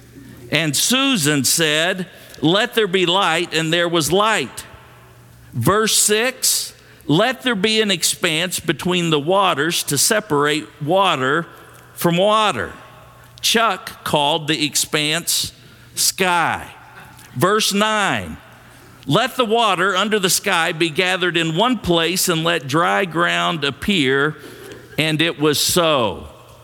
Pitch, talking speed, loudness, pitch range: 170 Hz, 120 wpm, -17 LUFS, 150-200 Hz